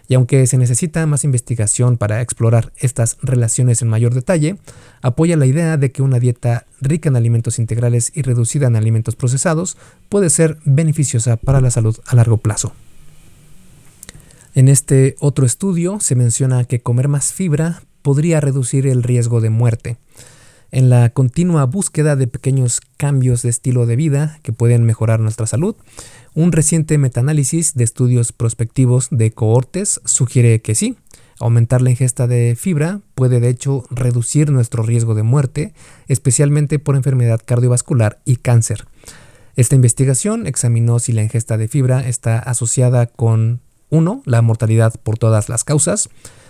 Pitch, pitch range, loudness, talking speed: 125 Hz, 120-145 Hz, -15 LUFS, 150 wpm